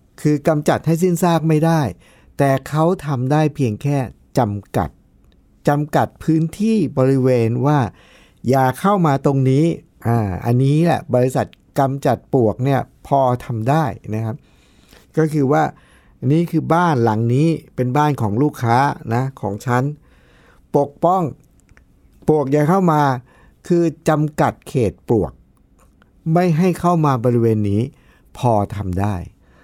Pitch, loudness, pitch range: 140 Hz, -18 LUFS, 120-155 Hz